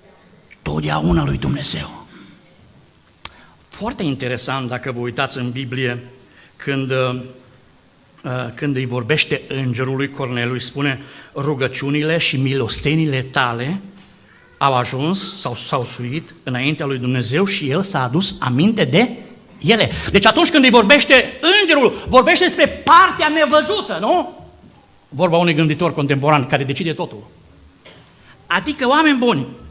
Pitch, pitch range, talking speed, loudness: 145 Hz, 130-195 Hz, 115 wpm, -16 LUFS